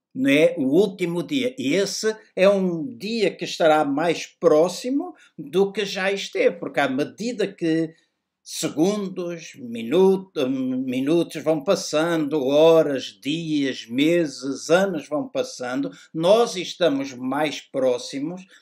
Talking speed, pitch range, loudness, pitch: 115 wpm, 165-260 Hz, -22 LUFS, 195 Hz